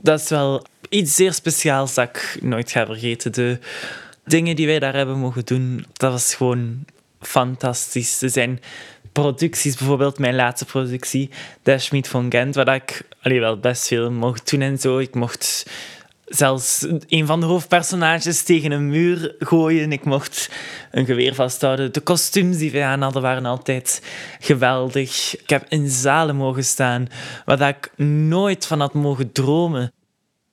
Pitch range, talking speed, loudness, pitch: 125-155 Hz, 160 wpm, -19 LUFS, 135 Hz